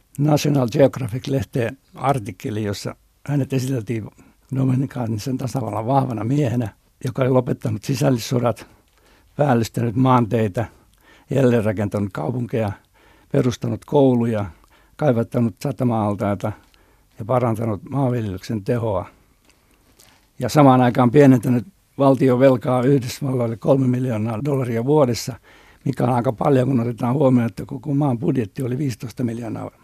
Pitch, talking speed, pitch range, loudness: 125 Hz, 105 wpm, 115-135 Hz, -20 LUFS